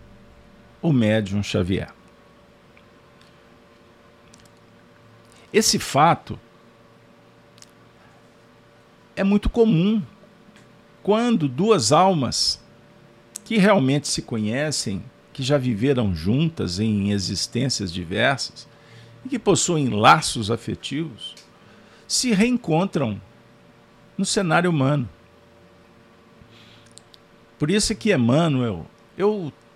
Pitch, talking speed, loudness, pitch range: 115 Hz, 80 wpm, -21 LUFS, 115-165 Hz